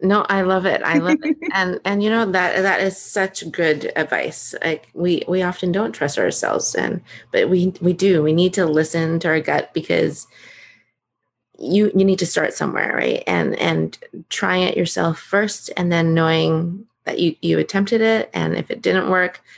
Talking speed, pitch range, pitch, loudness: 195 wpm, 165-195 Hz, 185 Hz, -19 LUFS